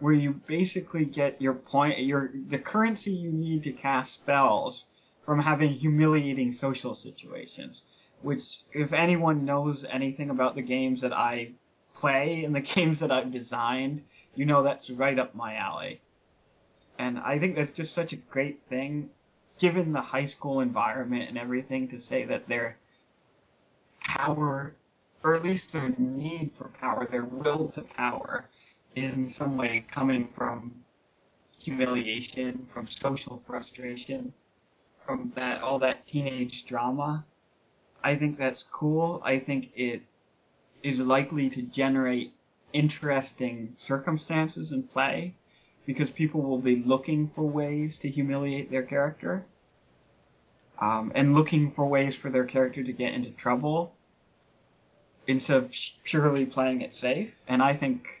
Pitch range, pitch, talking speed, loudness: 130-150 Hz, 135 Hz, 140 wpm, -29 LUFS